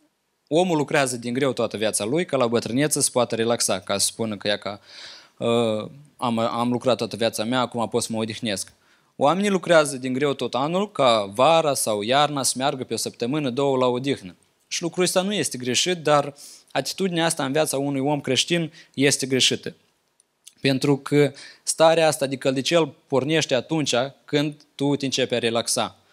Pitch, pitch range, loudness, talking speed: 135 Hz, 120-150 Hz, -22 LUFS, 185 wpm